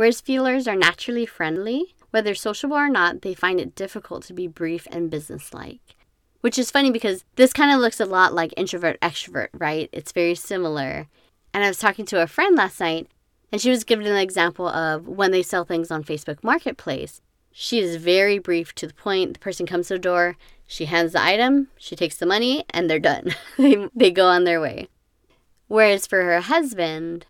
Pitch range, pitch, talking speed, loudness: 170-225 Hz, 185 Hz, 200 wpm, -21 LUFS